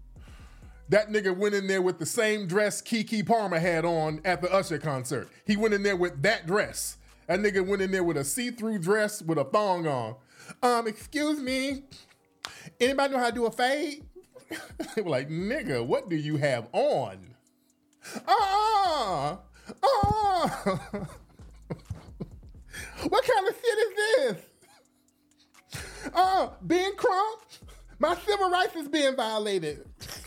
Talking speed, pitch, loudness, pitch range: 150 wpm, 220 Hz, -27 LUFS, 185-300 Hz